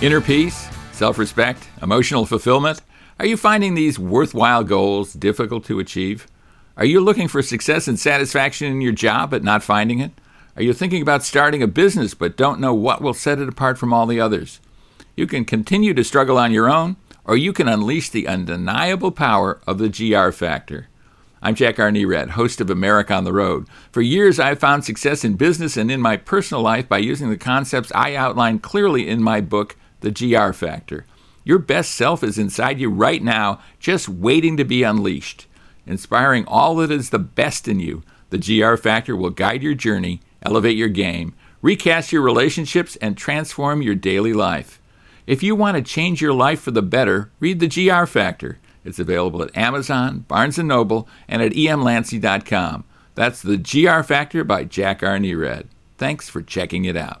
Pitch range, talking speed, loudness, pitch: 105-150 Hz, 185 wpm, -18 LUFS, 120 Hz